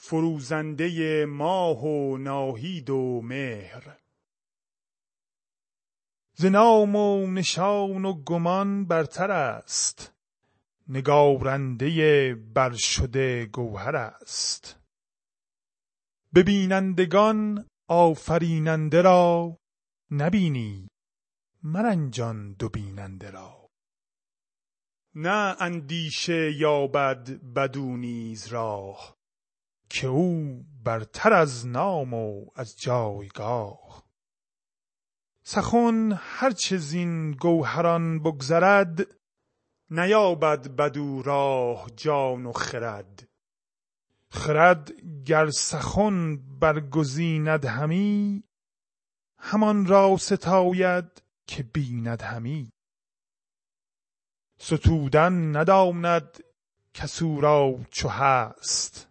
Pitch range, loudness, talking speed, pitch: 130-180 Hz, -24 LUFS, 70 wpm, 155 Hz